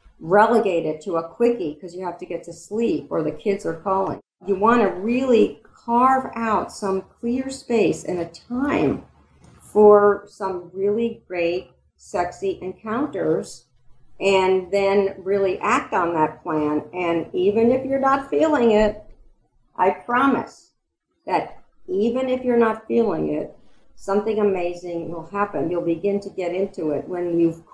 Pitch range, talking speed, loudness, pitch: 175-220 Hz, 150 wpm, -21 LUFS, 195 Hz